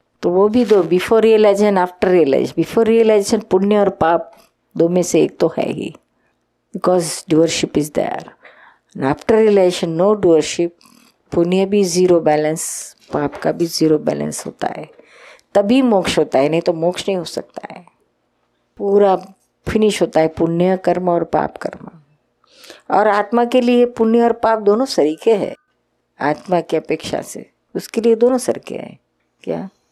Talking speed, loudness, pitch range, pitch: 160 wpm, -16 LUFS, 165-220 Hz, 190 Hz